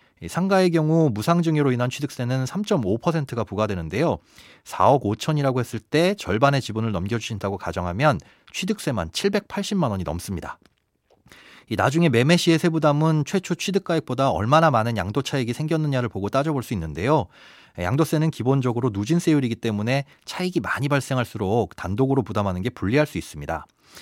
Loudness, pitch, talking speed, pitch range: -23 LUFS, 135 Hz, 365 characters per minute, 110-160 Hz